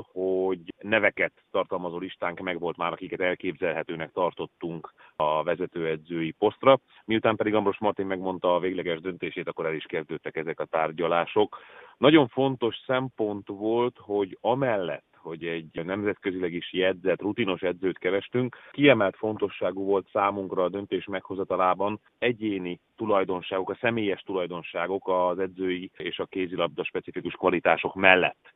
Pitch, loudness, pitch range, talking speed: 95 Hz, -27 LUFS, 90-110 Hz, 130 wpm